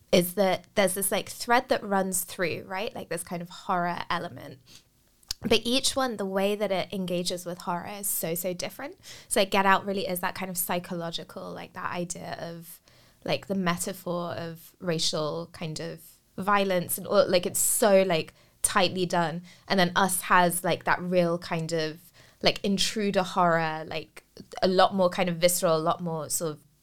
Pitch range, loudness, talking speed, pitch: 170-195 Hz, -27 LUFS, 190 wpm, 180 Hz